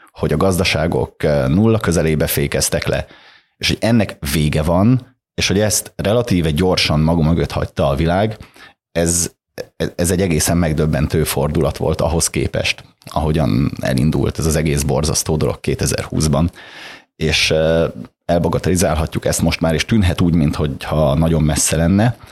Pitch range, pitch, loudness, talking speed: 75-95 Hz, 85 Hz, -17 LUFS, 135 wpm